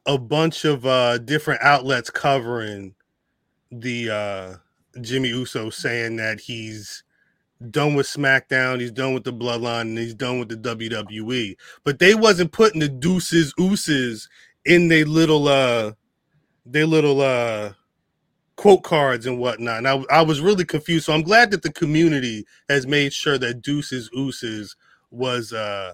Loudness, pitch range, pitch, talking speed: -20 LUFS, 120-155 Hz, 130 Hz, 155 wpm